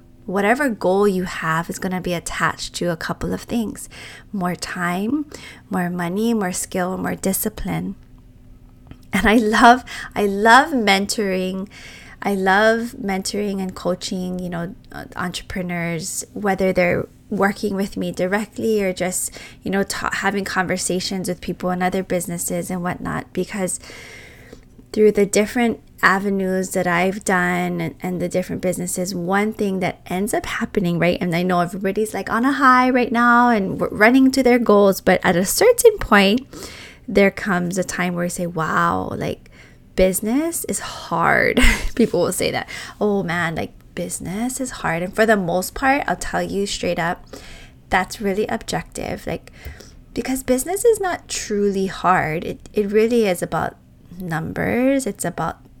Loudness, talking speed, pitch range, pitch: -19 LUFS, 160 wpm, 180-220 Hz, 190 Hz